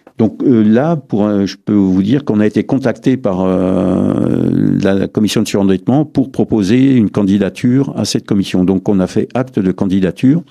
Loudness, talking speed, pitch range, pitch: -13 LUFS, 190 wpm, 95-125 Hz, 105 Hz